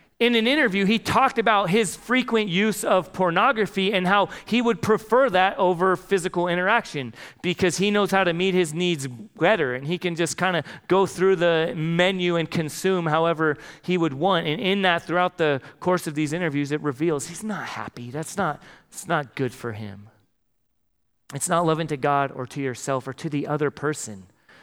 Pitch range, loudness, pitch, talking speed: 150-195 Hz, -23 LUFS, 175 Hz, 190 wpm